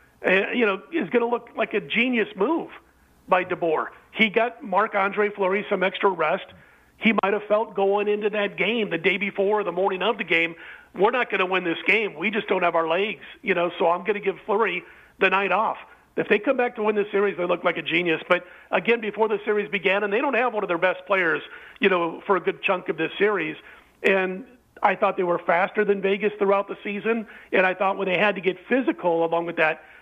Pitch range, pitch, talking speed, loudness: 185-210 Hz, 200 Hz, 240 wpm, -23 LUFS